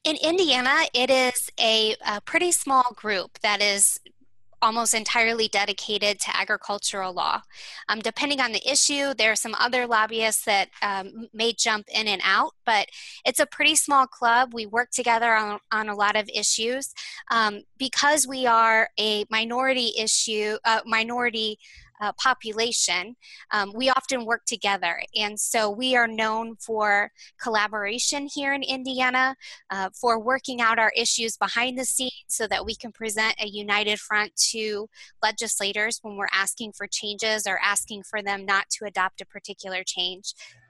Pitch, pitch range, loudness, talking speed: 220 Hz, 210-245 Hz, -23 LUFS, 160 wpm